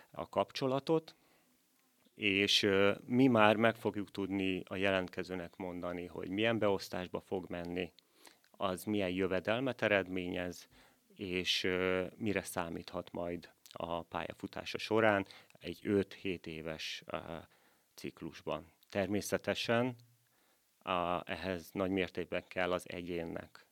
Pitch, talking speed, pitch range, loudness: 95 Hz, 105 wpm, 90-105 Hz, -35 LUFS